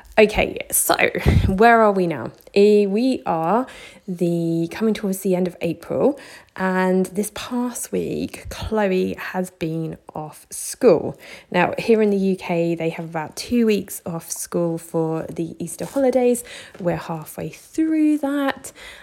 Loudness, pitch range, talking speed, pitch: -21 LUFS, 170-225 Hz, 140 wpm, 190 Hz